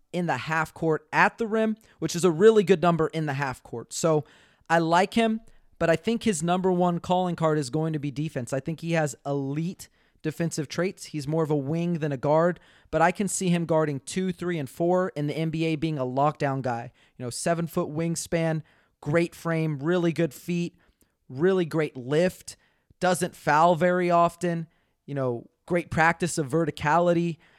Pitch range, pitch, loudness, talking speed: 150-175 Hz, 165 Hz, -26 LUFS, 195 wpm